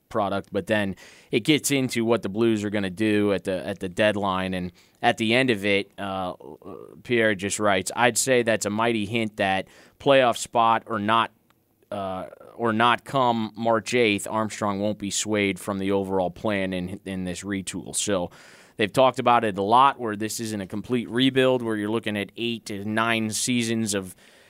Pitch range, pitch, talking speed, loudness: 100-115 Hz, 105 Hz, 195 wpm, -24 LUFS